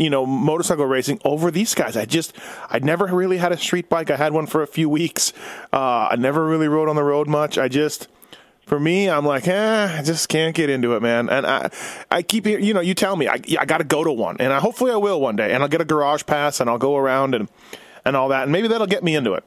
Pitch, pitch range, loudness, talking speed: 155 Hz, 145-180 Hz, -19 LUFS, 275 wpm